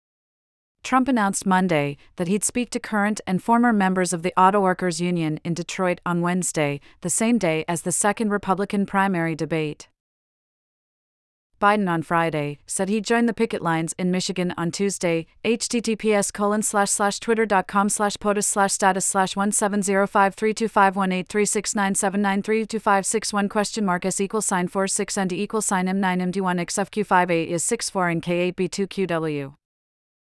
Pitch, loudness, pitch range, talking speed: 195 Hz, -22 LUFS, 175-205 Hz, 160 wpm